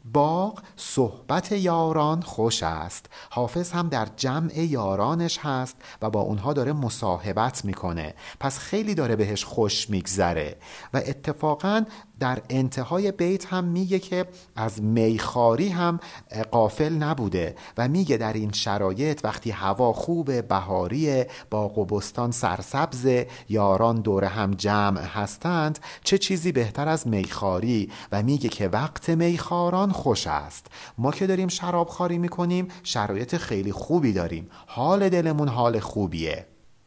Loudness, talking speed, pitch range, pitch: -25 LUFS, 130 wpm, 105-170 Hz, 130 Hz